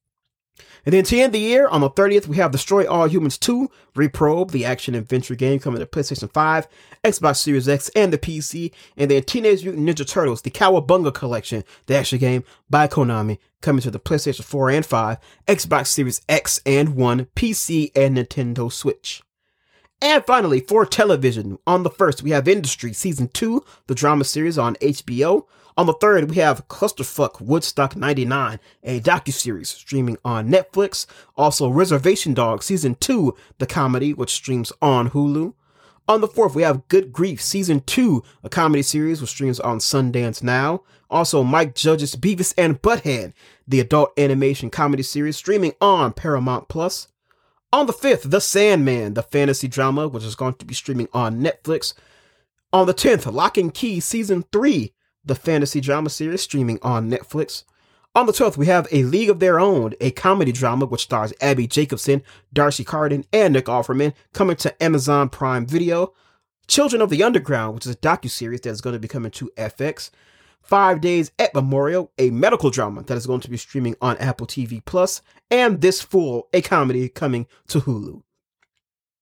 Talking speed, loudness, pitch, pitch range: 175 wpm, -19 LUFS, 145 Hz, 130-180 Hz